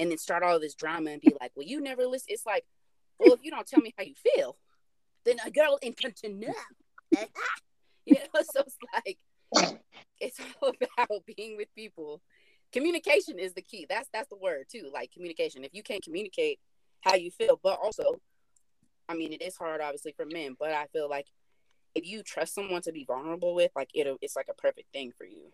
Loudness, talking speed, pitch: -30 LUFS, 215 wpm, 210 Hz